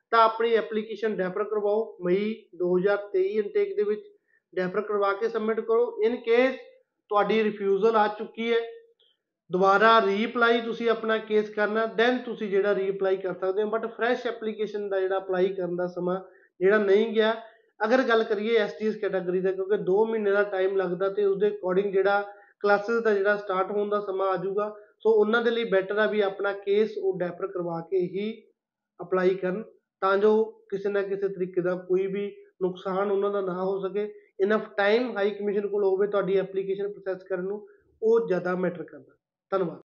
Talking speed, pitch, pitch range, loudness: 180 wpm, 205 Hz, 190-220 Hz, -26 LUFS